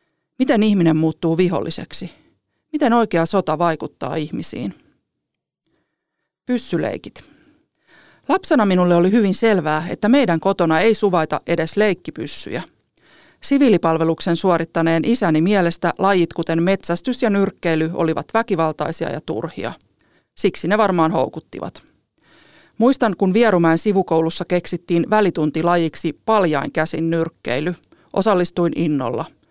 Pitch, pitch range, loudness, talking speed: 175 Hz, 165-210 Hz, -18 LUFS, 100 wpm